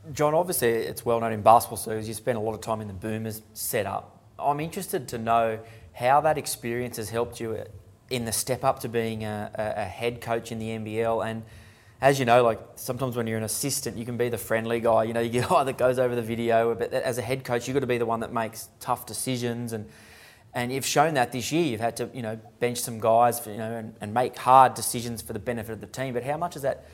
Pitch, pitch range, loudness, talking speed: 115 Hz, 110-125 Hz, -26 LUFS, 260 wpm